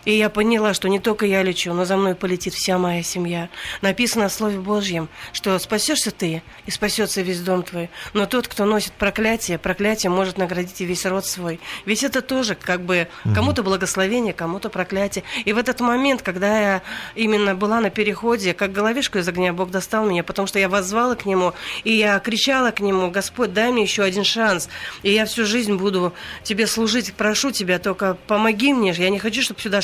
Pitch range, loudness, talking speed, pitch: 185-220 Hz, -20 LUFS, 200 wpm, 200 Hz